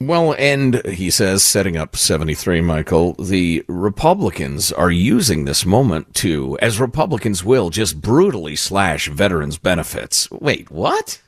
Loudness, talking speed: -16 LUFS, 135 wpm